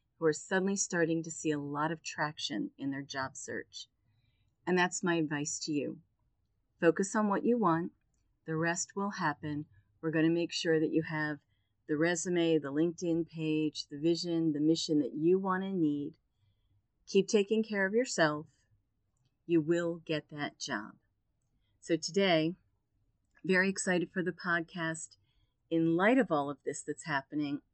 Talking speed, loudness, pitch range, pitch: 165 wpm, -32 LUFS, 135-170 Hz, 160 Hz